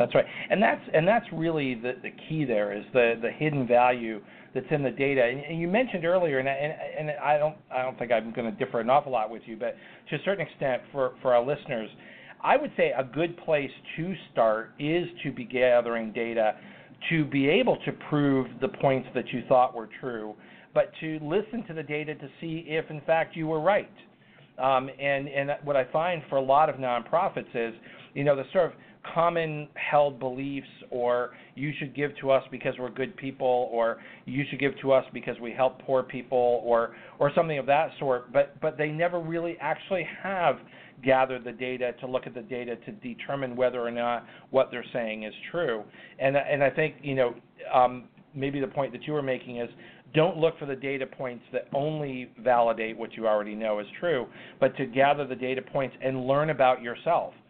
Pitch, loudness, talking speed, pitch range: 135 Hz, -28 LUFS, 210 wpm, 125-150 Hz